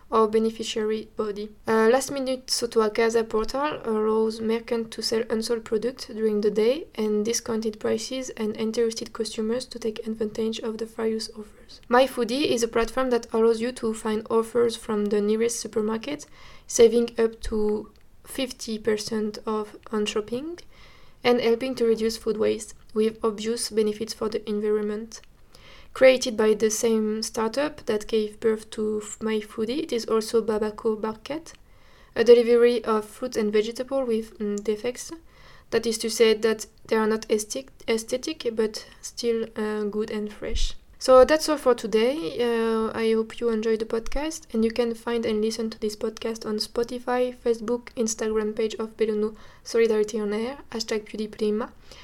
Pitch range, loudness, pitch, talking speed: 220-235 Hz, -25 LUFS, 225 Hz, 160 wpm